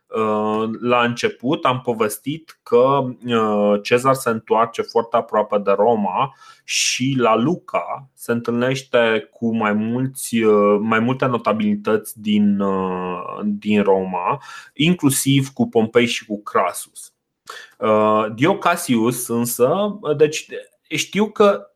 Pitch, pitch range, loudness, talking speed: 120 Hz, 110-140 Hz, -19 LUFS, 100 wpm